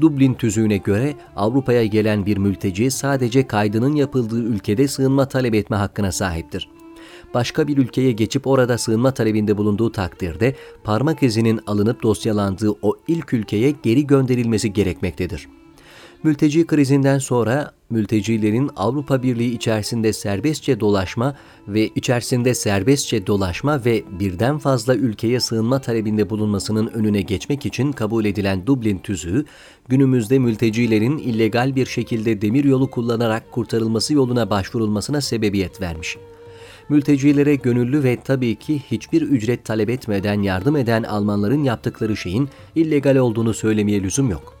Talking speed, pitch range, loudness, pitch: 125 wpm, 105-135 Hz, -19 LUFS, 115 Hz